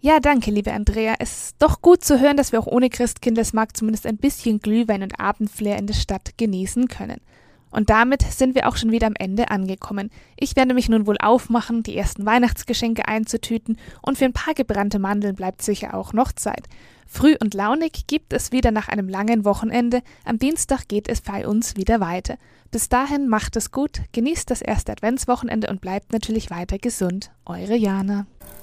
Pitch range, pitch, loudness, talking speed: 210-250 Hz, 225 Hz, -21 LUFS, 190 wpm